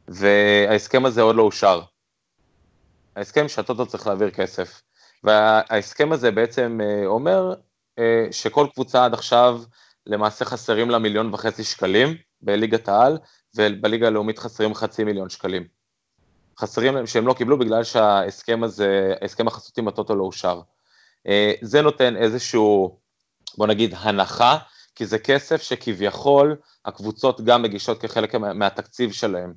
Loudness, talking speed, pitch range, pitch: -20 LUFS, 125 wpm, 105-125 Hz, 110 Hz